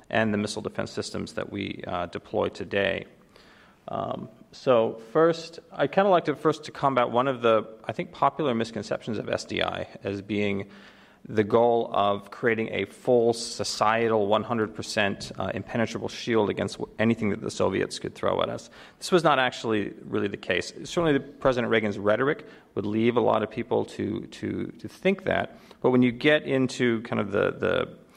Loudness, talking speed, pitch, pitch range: -26 LUFS, 180 wpm, 115 Hz, 110-135 Hz